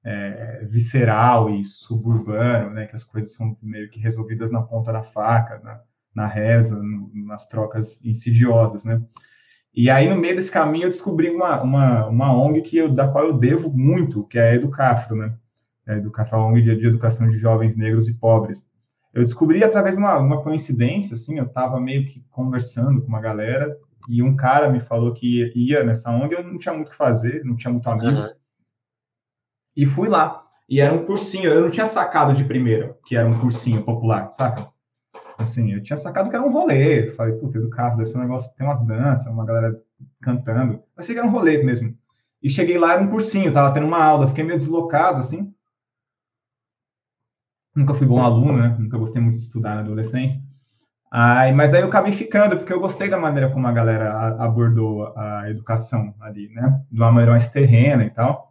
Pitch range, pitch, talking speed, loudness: 115-140 Hz, 120 Hz, 200 wpm, -19 LUFS